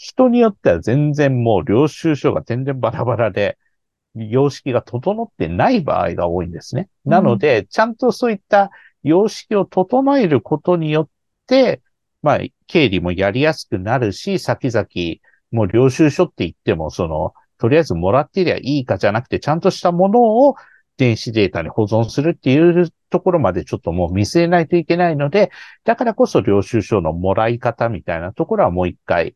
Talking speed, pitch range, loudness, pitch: 370 characters per minute, 115-185 Hz, -17 LUFS, 145 Hz